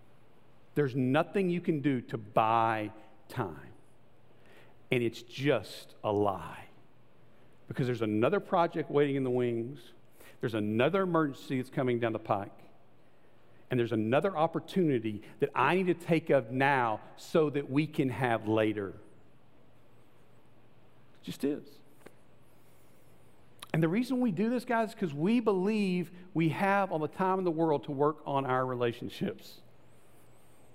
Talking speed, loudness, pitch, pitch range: 140 wpm, -31 LUFS, 140 Hz, 120-165 Hz